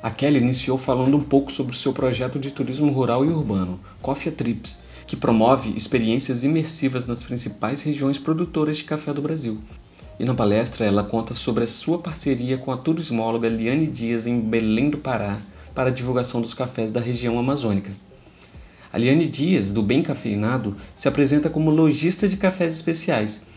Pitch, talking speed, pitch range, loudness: 130 Hz, 175 wpm, 115-145 Hz, -22 LUFS